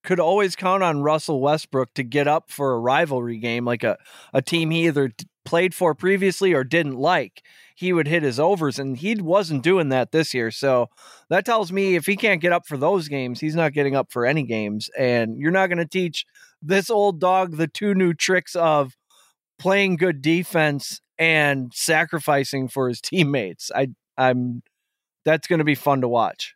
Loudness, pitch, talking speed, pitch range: -21 LUFS, 160 Hz, 195 wpm, 135-180 Hz